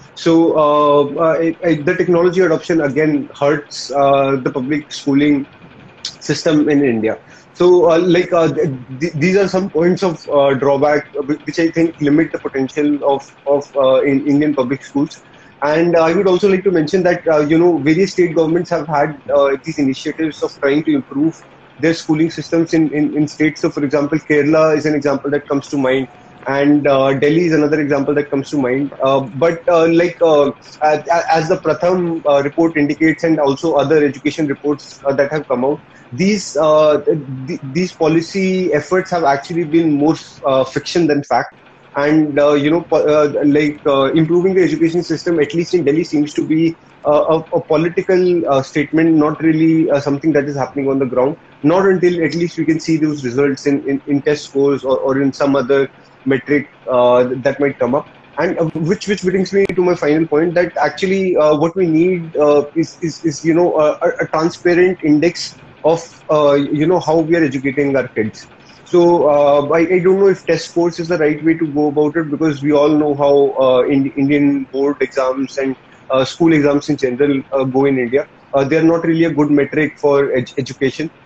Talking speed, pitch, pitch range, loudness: 200 wpm, 150 Hz, 140-165 Hz, -15 LUFS